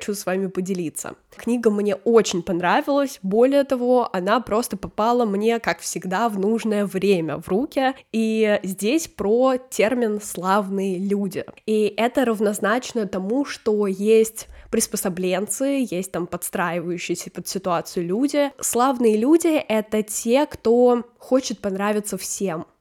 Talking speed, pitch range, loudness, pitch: 125 wpm, 190-240 Hz, -21 LUFS, 210 Hz